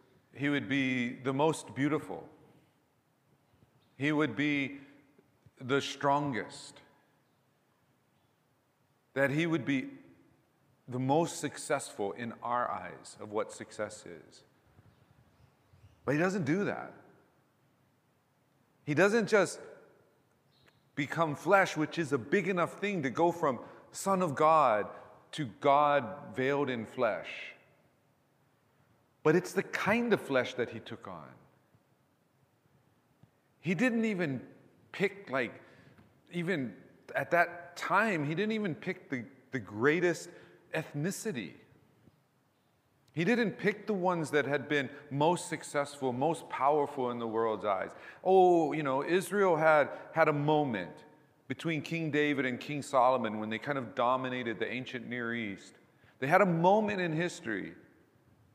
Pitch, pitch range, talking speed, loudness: 145 Hz, 130-165 Hz, 125 wpm, -31 LUFS